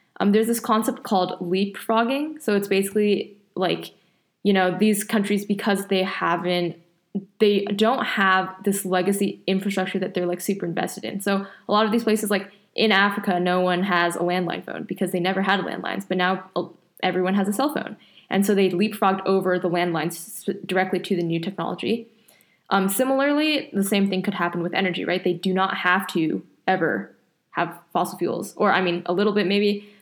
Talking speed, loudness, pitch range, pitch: 190 wpm, -23 LUFS, 180-205 Hz, 195 Hz